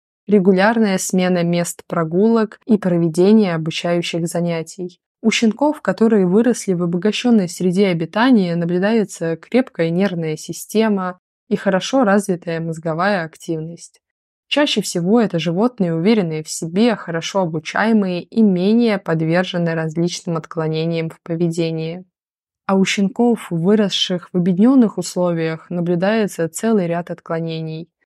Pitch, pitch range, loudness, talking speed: 180 Hz, 170-210 Hz, -18 LUFS, 110 wpm